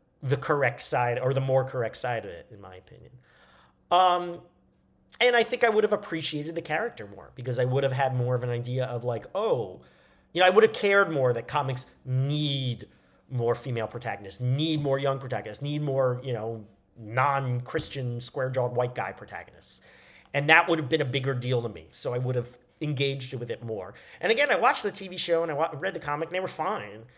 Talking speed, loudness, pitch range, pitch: 215 wpm, -27 LUFS, 120-155 Hz, 130 Hz